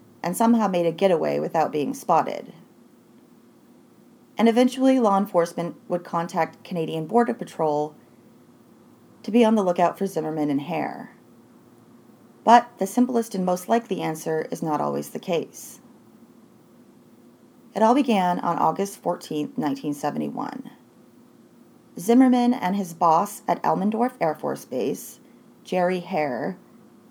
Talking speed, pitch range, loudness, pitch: 125 wpm, 160-230 Hz, -23 LUFS, 185 Hz